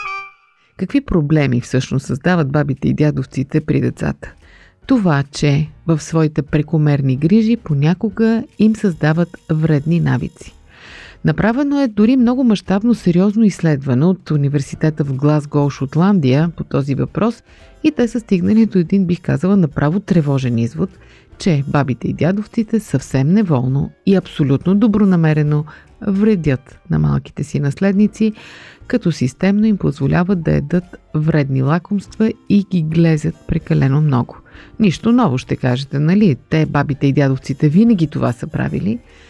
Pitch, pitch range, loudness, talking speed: 160 Hz, 140-200 Hz, -16 LUFS, 130 wpm